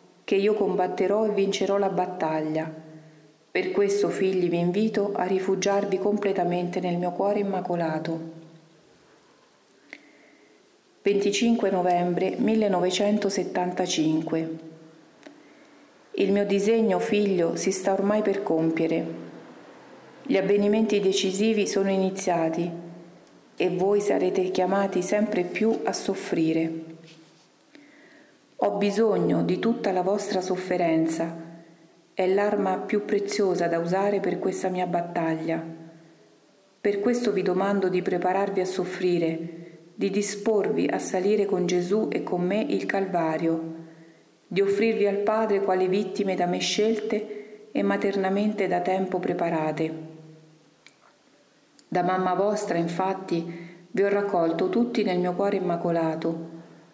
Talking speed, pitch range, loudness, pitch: 110 wpm, 170-205 Hz, -25 LUFS, 190 Hz